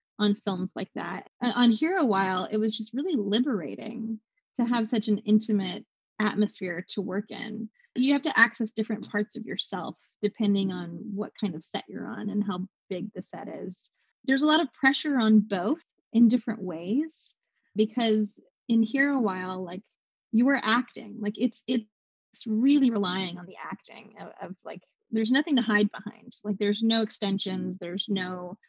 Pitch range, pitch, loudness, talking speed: 200-240 Hz, 215 Hz, -27 LUFS, 175 wpm